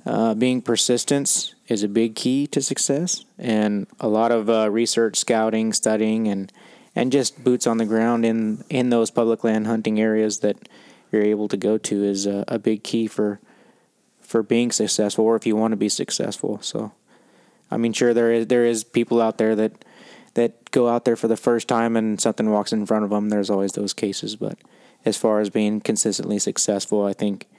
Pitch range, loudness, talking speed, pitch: 105-115 Hz, -21 LUFS, 200 wpm, 110 Hz